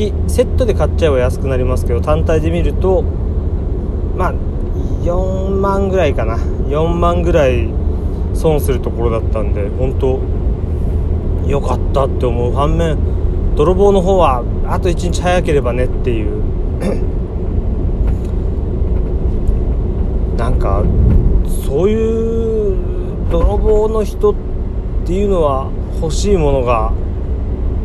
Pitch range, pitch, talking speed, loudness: 80-95 Hz, 85 Hz, 215 characters per minute, -16 LUFS